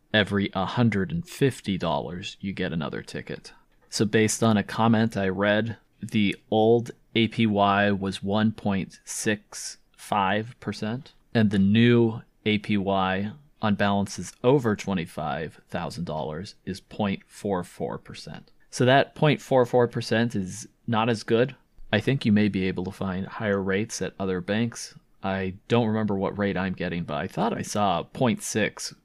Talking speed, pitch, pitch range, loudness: 125 wpm, 105 Hz, 95-115 Hz, -25 LUFS